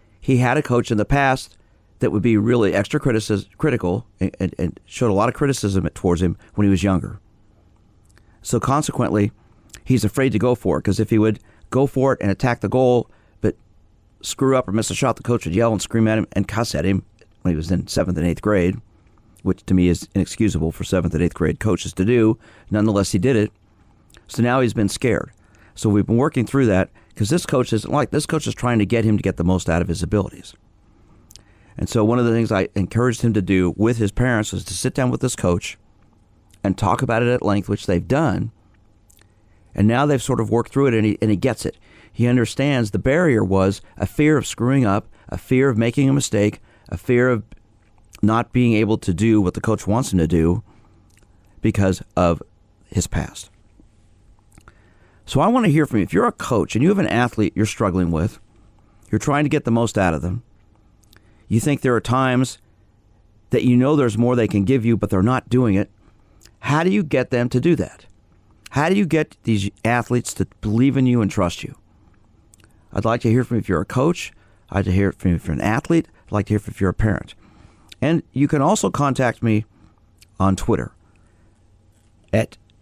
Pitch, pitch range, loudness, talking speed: 105 Hz, 100-120 Hz, -20 LUFS, 220 wpm